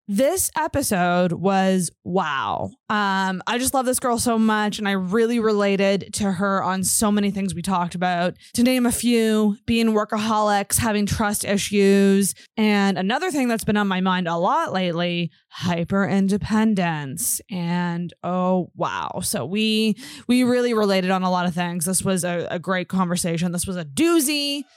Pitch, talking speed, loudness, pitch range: 195 Hz, 170 wpm, -21 LUFS, 180-220 Hz